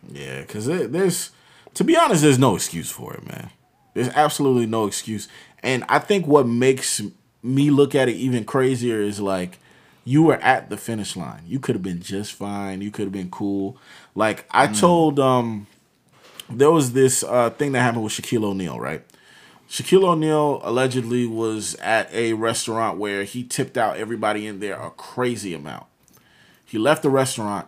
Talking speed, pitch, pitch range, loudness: 180 wpm, 120 Hz, 105-135 Hz, -21 LUFS